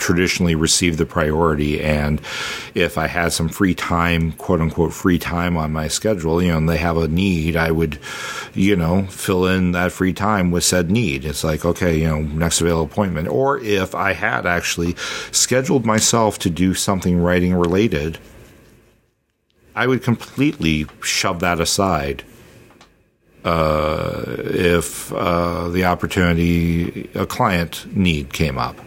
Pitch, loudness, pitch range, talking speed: 85 Hz, -18 LUFS, 80-95 Hz, 150 wpm